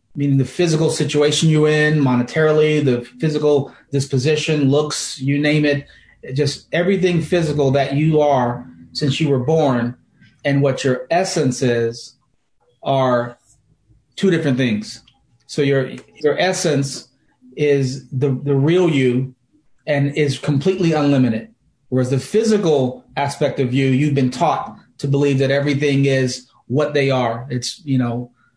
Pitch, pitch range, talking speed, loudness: 140 Hz, 130-150 Hz, 140 wpm, -18 LUFS